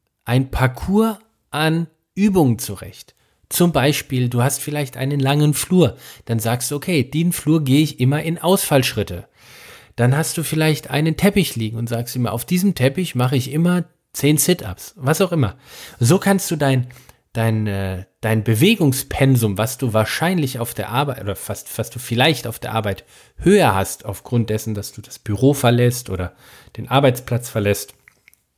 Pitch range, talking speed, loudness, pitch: 115-155 Hz, 165 wpm, -19 LUFS, 130 Hz